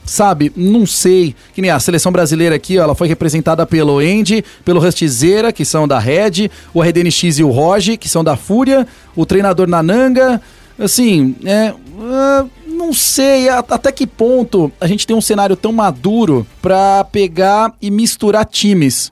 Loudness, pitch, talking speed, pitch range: -12 LUFS, 195 Hz, 165 wpm, 165-225 Hz